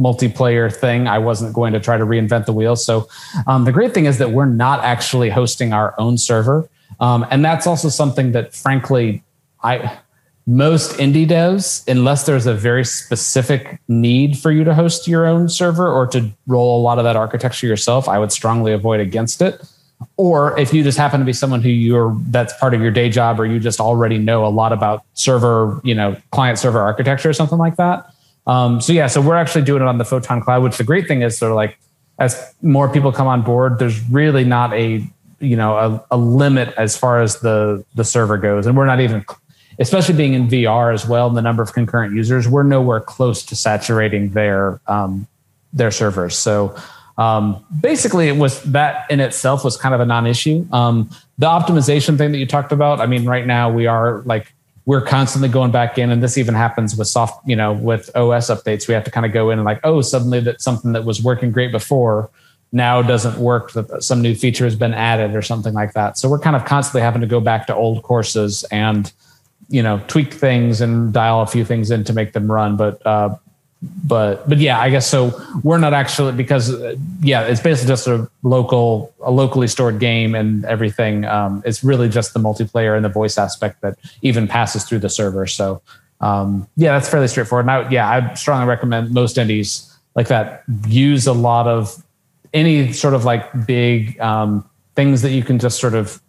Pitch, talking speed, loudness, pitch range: 120 Hz, 215 wpm, -16 LUFS, 115-135 Hz